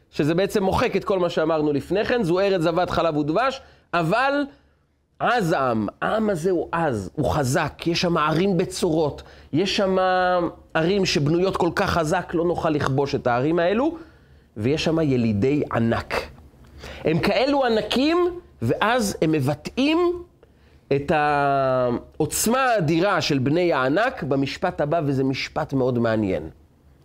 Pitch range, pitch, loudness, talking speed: 140-190 Hz, 165 Hz, -22 LUFS, 135 wpm